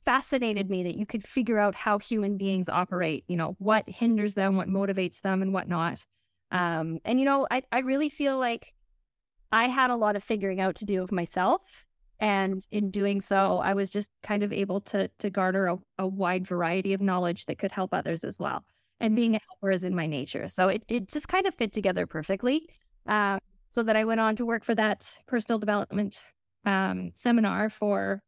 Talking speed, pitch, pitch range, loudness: 210 wpm, 200 Hz, 185-225 Hz, -28 LUFS